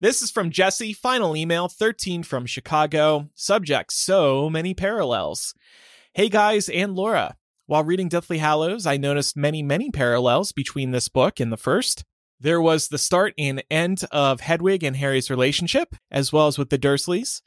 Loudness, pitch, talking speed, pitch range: -22 LUFS, 160 Hz, 170 wpm, 140-190 Hz